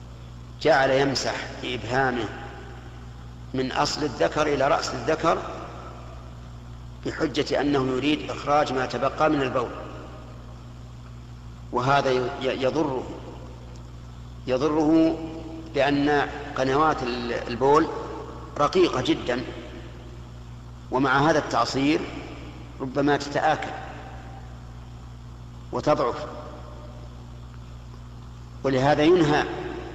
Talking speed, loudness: 70 wpm, -24 LUFS